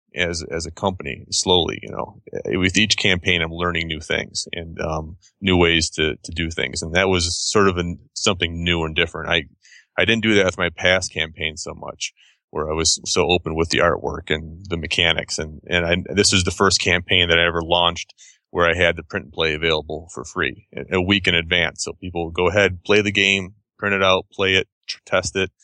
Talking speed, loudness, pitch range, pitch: 220 wpm, -19 LUFS, 80-95 Hz, 85 Hz